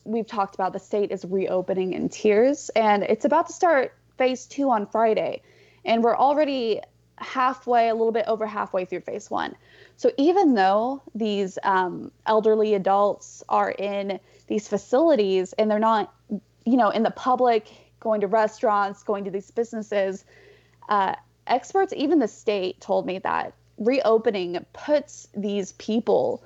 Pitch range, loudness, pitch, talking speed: 200-250 Hz, -23 LUFS, 220 Hz, 155 wpm